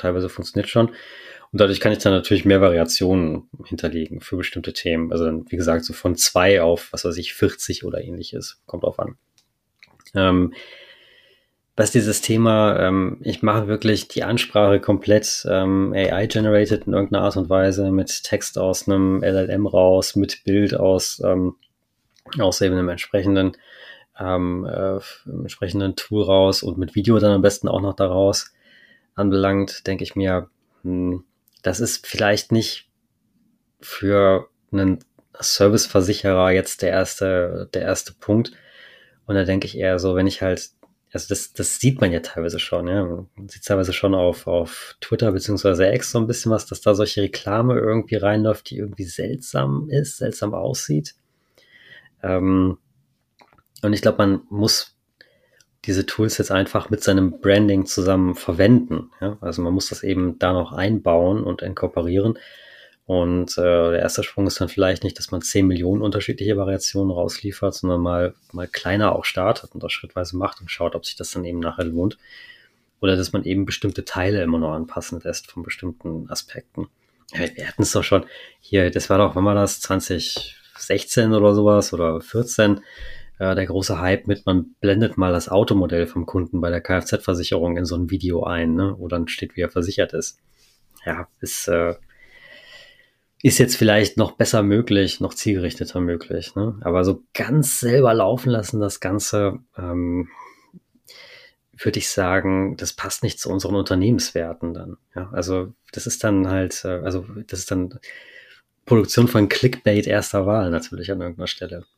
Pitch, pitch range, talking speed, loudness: 95 Hz, 90-105 Hz, 165 wpm, -20 LUFS